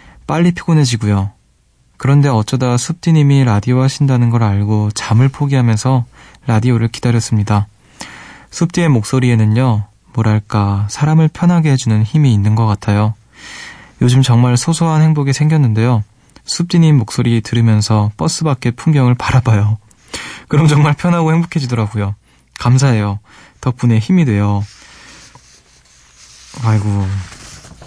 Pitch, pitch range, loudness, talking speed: 120 Hz, 105-140 Hz, -13 LUFS, 300 characters per minute